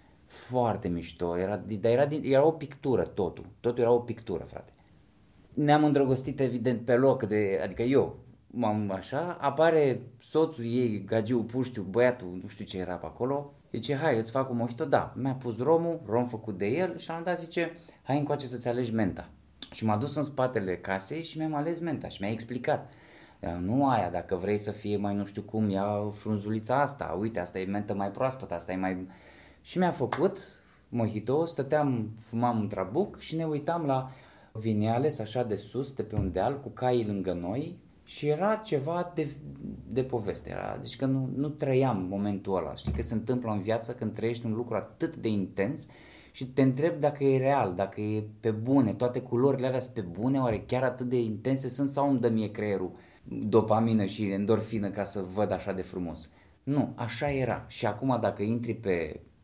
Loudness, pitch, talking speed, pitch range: -30 LUFS, 120 Hz, 190 wpm, 105-135 Hz